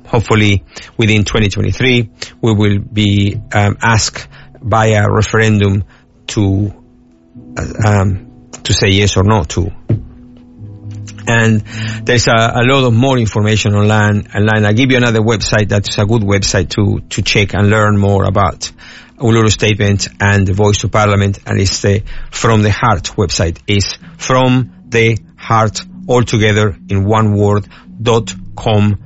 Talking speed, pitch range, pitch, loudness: 145 wpm, 100-115 Hz, 105 Hz, -12 LUFS